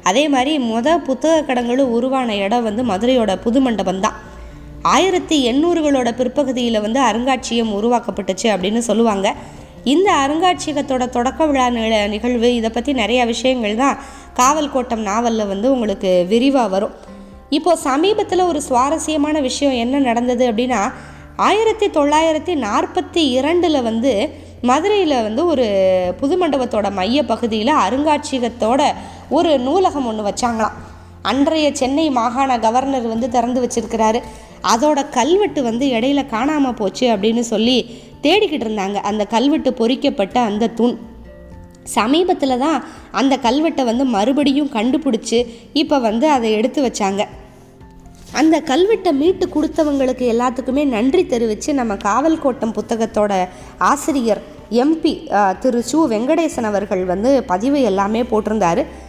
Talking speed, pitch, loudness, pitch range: 120 wpm, 250 Hz, -17 LUFS, 225-290 Hz